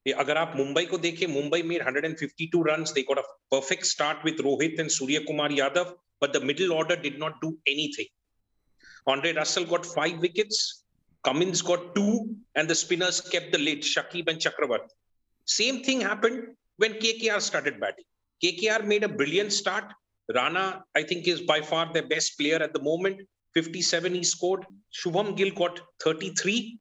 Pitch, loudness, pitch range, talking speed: 175 Hz, -27 LUFS, 155-195 Hz, 175 wpm